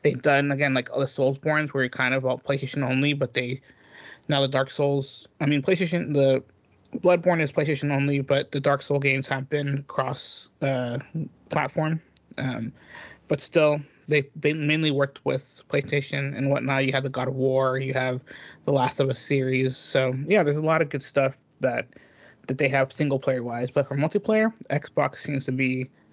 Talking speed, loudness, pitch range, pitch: 190 wpm, -25 LUFS, 130-145 Hz, 140 Hz